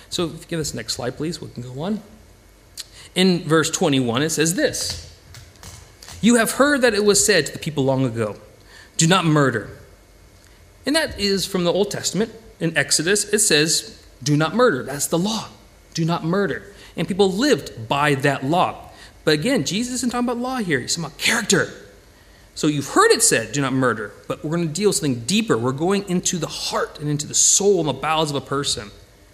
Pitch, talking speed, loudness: 150 Hz, 210 wpm, -20 LUFS